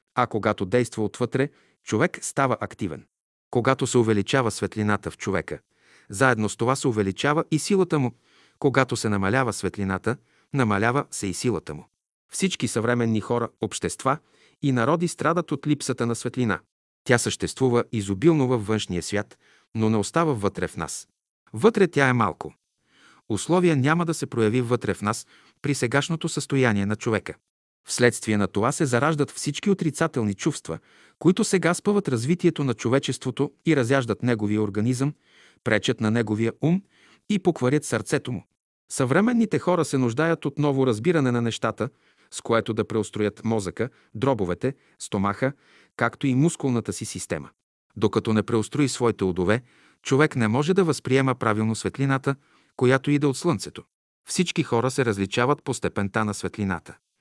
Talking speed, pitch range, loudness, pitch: 150 wpm, 110-145 Hz, -24 LUFS, 125 Hz